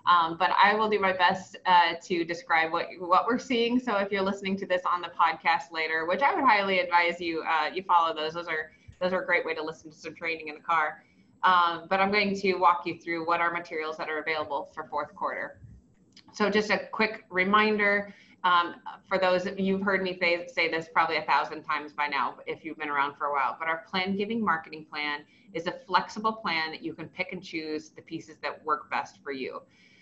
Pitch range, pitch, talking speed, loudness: 160-190 Hz, 175 Hz, 235 wpm, -27 LUFS